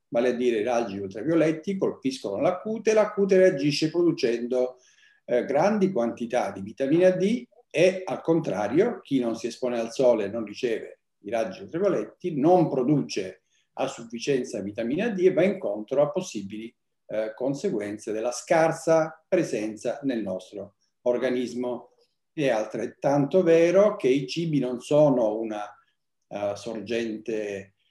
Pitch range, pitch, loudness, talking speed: 115-180 Hz, 130 Hz, -25 LUFS, 140 wpm